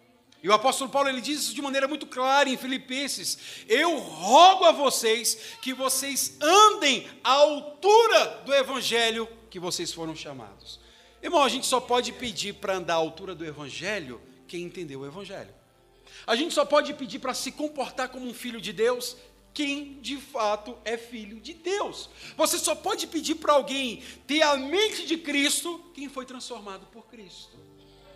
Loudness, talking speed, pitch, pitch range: -24 LUFS, 170 wpm, 260 Hz, 215-290 Hz